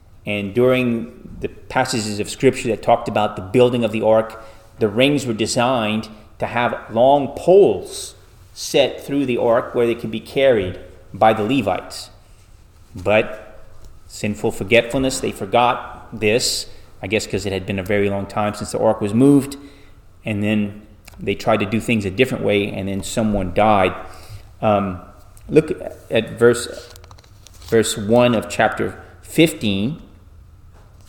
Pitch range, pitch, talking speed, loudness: 95-120 Hz, 105 Hz, 150 wpm, -18 LUFS